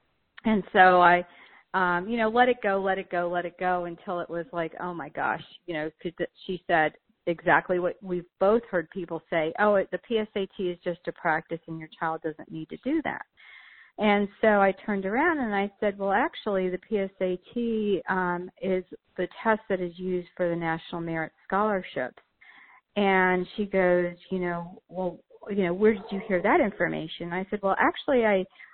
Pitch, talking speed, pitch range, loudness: 185 Hz, 195 wpm, 175-205 Hz, -27 LUFS